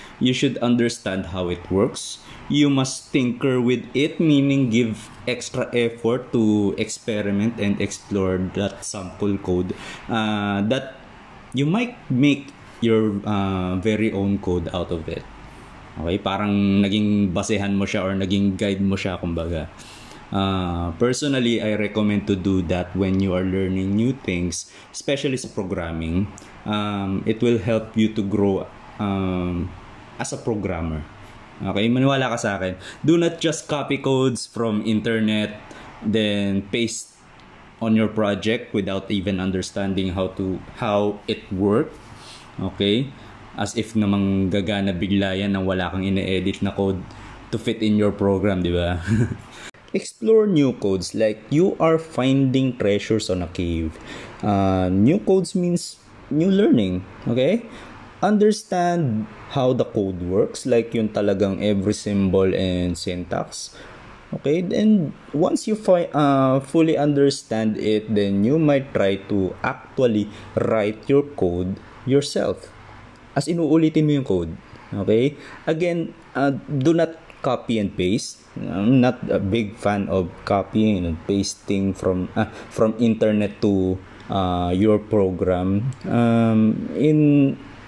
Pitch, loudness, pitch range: 105 Hz, -22 LUFS, 95-125 Hz